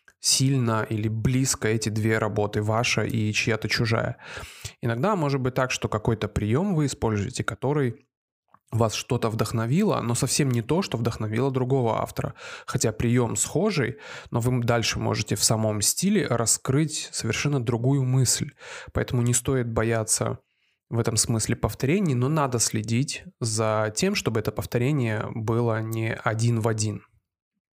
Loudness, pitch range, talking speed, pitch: -25 LUFS, 110-135 Hz, 145 wpm, 120 Hz